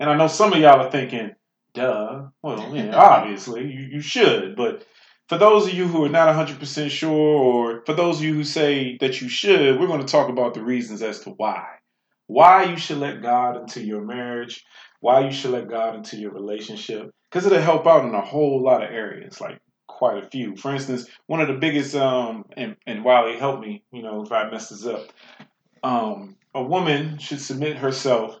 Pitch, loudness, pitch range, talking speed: 140 Hz, -20 LUFS, 120-160 Hz, 215 wpm